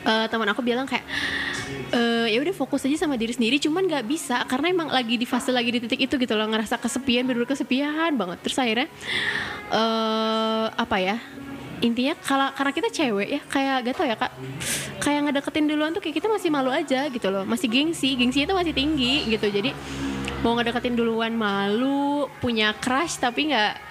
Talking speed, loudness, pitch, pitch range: 190 wpm, -24 LUFS, 255 Hz, 230-285 Hz